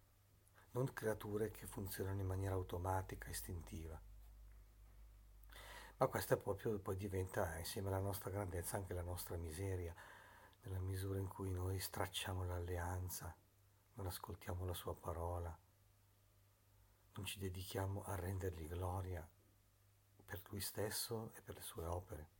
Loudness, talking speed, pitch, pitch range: -46 LUFS, 125 wpm, 95 Hz, 90-100 Hz